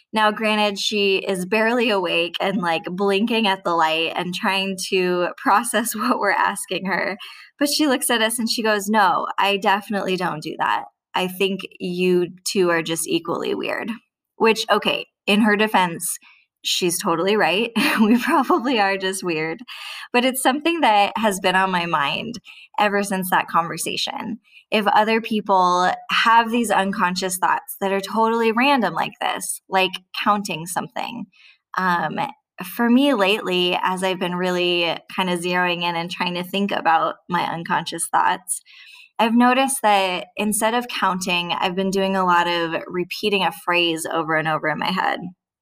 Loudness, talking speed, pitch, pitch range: -20 LUFS, 165 wpm, 195 Hz, 180-225 Hz